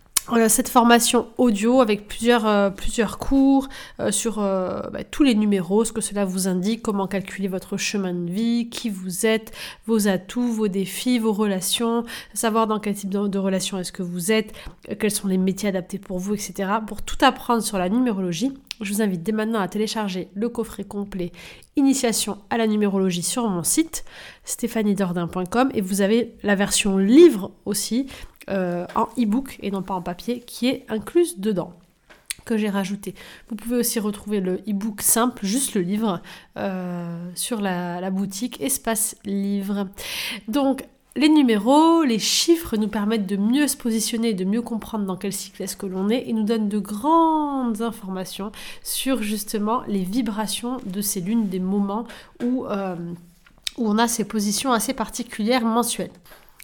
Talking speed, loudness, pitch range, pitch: 175 wpm, -22 LUFS, 195-235 Hz, 215 Hz